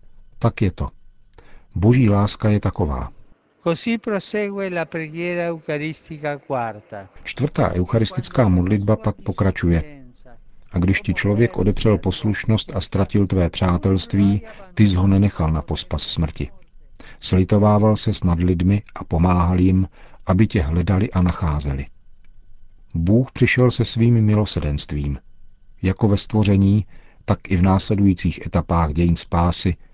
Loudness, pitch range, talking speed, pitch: -20 LUFS, 90-110 Hz, 110 wpm, 100 Hz